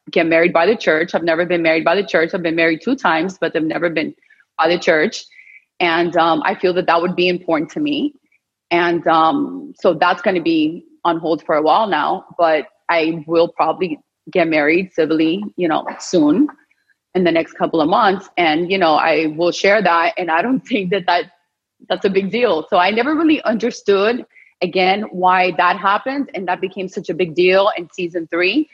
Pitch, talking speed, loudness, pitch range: 180 Hz, 205 wpm, -16 LUFS, 165-215 Hz